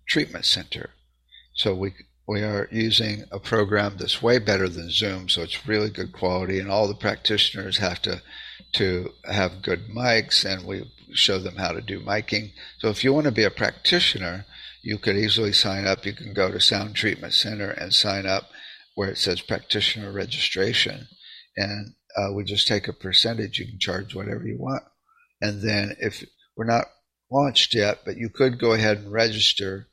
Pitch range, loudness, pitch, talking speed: 95-110 Hz, -23 LUFS, 105 Hz, 185 wpm